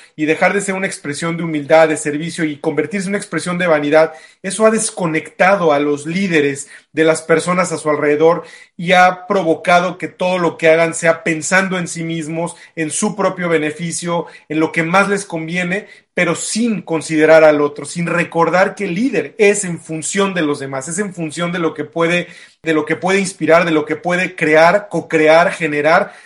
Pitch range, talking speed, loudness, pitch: 160-185 Hz, 200 wpm, -15 LUFS, 165 Hz